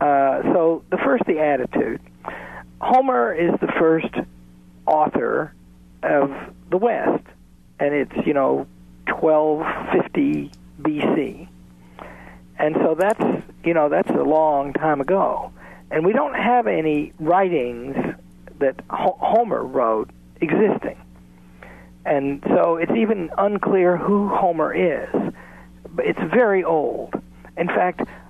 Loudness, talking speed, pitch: -20 LUFS, 125 wpm, 135 Hz